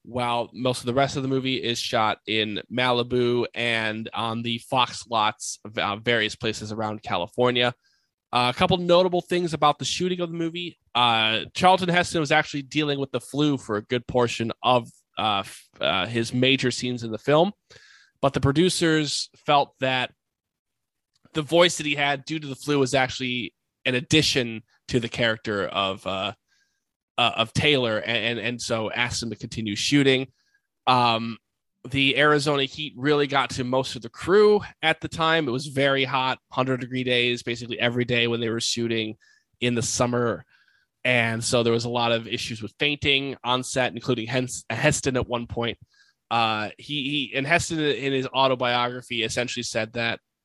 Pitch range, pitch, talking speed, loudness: 115-145 Hz, 125 Hz, 180 wpm, -24 LUFS